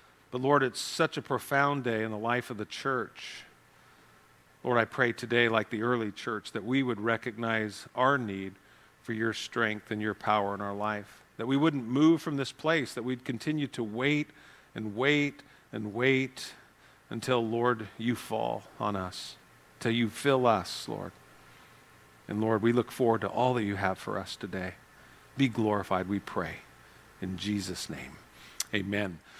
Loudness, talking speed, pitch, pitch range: -30 LUFS, 170 wpm, 115 Hz, 105-130 Hz